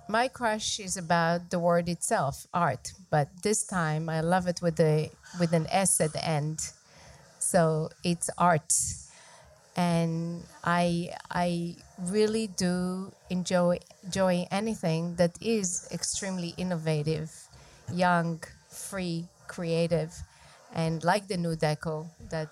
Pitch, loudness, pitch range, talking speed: 175 Hz, -29 LUFS, 165-185 Hz, 125 wpm